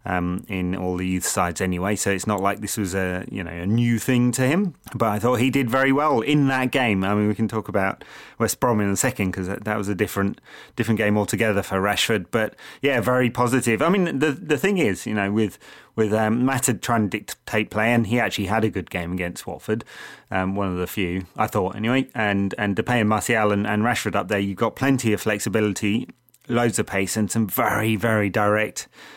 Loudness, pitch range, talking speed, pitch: -22 LUFS, 100-120 Hz, 235 wpm, 105 Hz